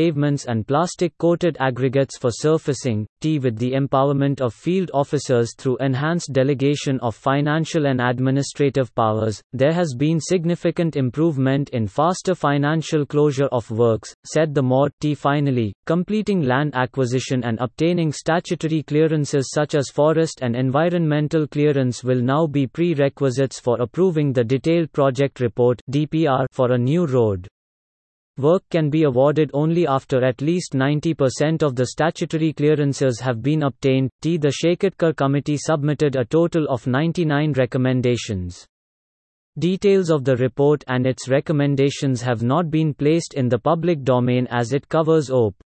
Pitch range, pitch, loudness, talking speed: 130-160 Hz, 140 Hz, -20 LUFS, 145 wpm